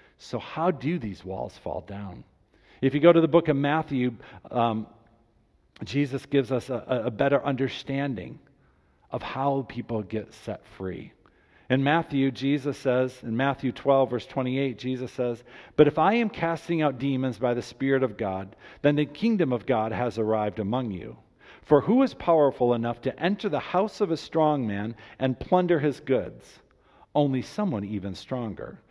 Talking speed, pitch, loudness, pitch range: 170 wpm, 130 Hz, -26 LUFS, 115-150 Hz